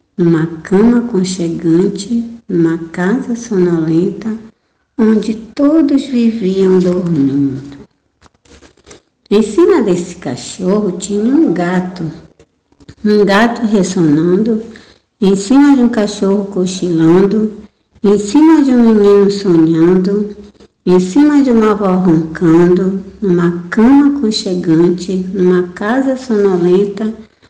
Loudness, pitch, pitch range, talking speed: -12 LUFS, 195 Hz, 180-225 Hz, 95 wpm